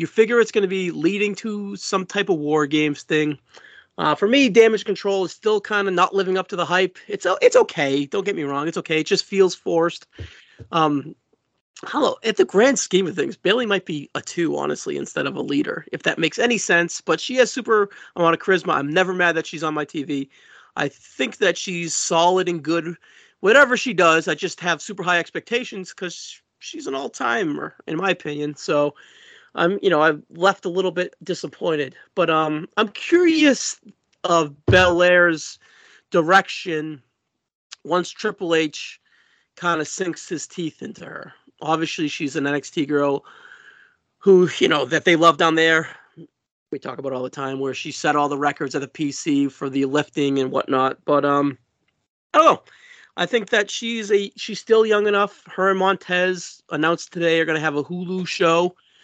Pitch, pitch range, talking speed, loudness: 175 Hz, 155-200 Hz, 195 wpm, -20 LUFS